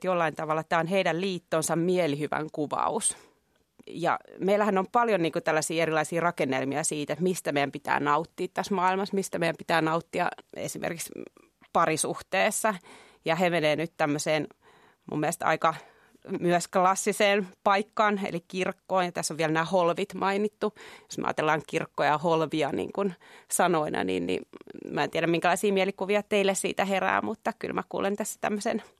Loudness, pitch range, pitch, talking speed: -27 LUFS, 160-195 Hz, 180 Hz, 160 wpm